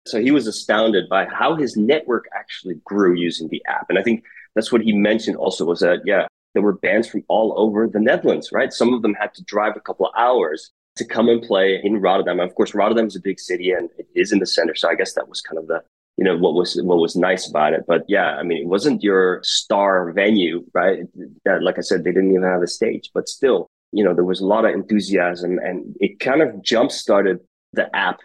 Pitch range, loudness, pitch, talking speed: 90-110 Hz, -19 LUFS, 100 Hz, 250 wpm